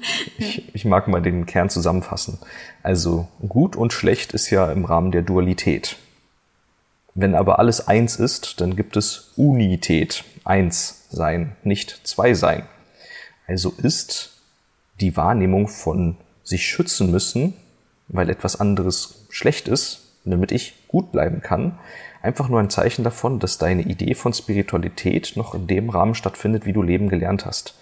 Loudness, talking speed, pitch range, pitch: -20 LUFS, 150 wpm, 90-110 Hz, 95 Hz